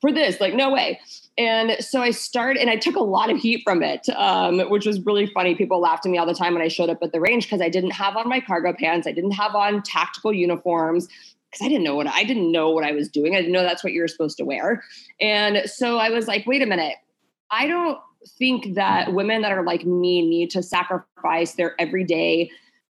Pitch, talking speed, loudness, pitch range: 190 Hz, 245 wpm, -21 LUFS, 175-225 Hz